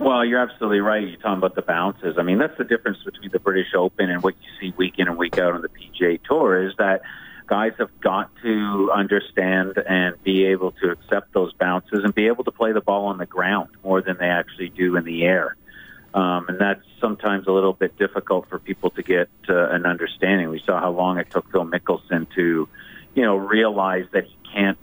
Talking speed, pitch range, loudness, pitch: 225 wpm, 90-100 Hz, -21 LUFS, 95 Hz